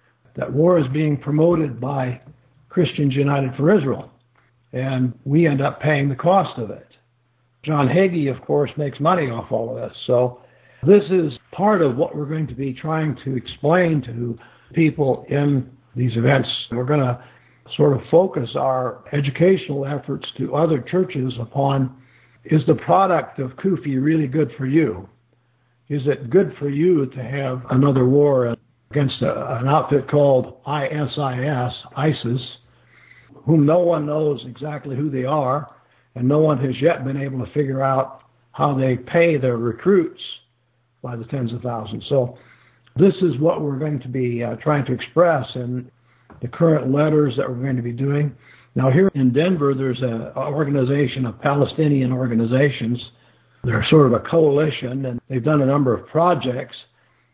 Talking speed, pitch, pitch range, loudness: 165 wpm, 135 Hz, 125-150 Hz, -20 LUFS